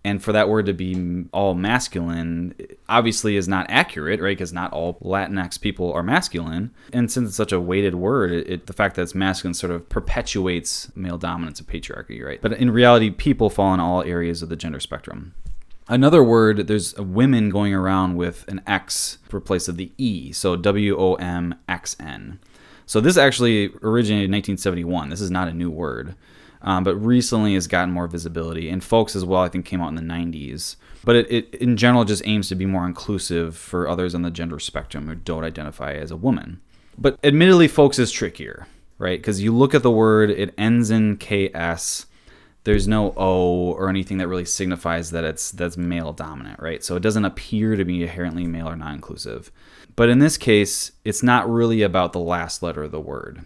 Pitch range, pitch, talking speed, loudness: 85-105 Hz, 95 Hz, 200 wpm, -20 LUFS